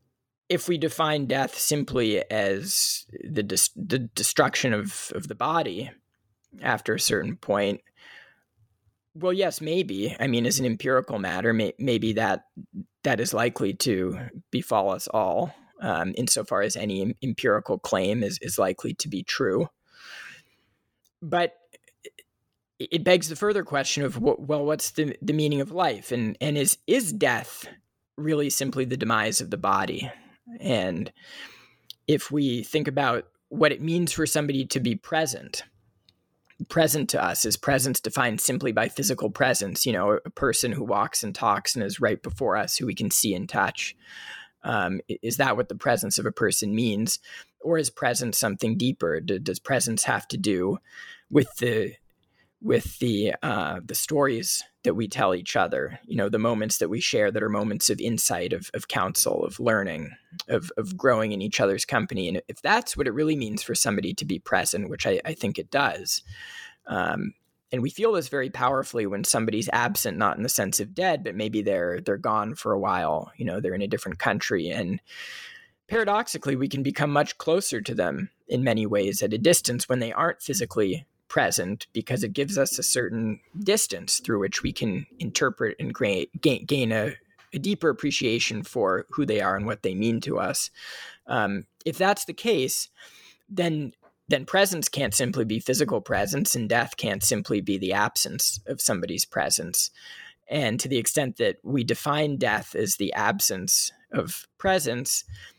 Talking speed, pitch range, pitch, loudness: 175 wpm, 115-175 Hz, 140 Hz, -25 LUFS